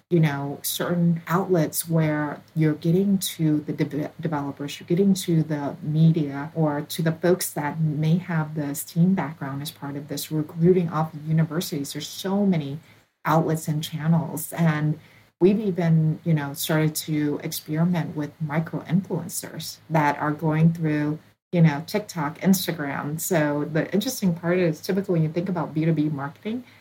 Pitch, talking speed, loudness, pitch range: 160 Hz, 160 wpm, -24 LUFS, 150-170 Hz